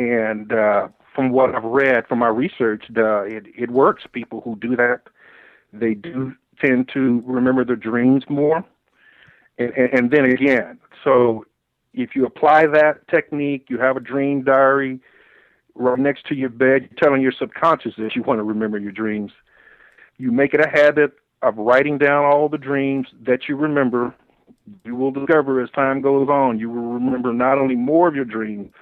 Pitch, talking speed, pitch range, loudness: 130 Hz, 180 wpm, 120-140 Hz, -18 LUFS